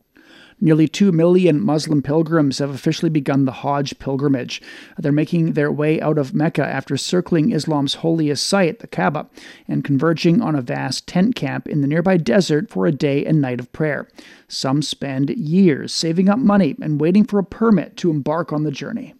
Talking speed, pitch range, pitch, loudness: 185 wpm, 145-180 Hz, 155 Hz, -18 LUFS